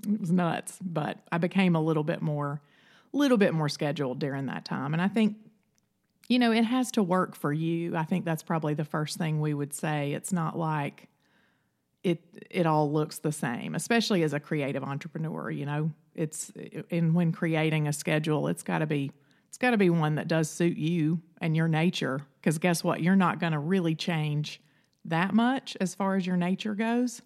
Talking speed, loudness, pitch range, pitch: 210 wpm, -28 LUFS, 155-195 Hz, 165 Hz